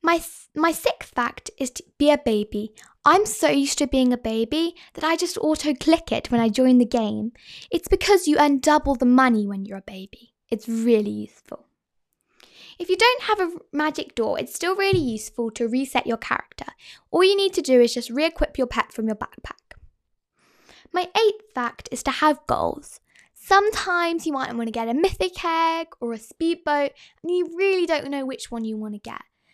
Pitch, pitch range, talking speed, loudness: 290 Hz, 235-345 Hz, 205 wpm, -22 LUFS